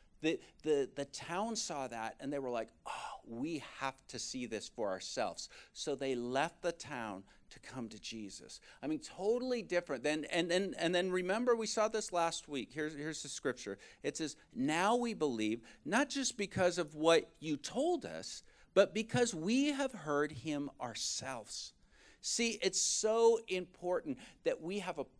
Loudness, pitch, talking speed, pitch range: -37 LUFS, 175 Hz, 180 wpm, 140-220 Hz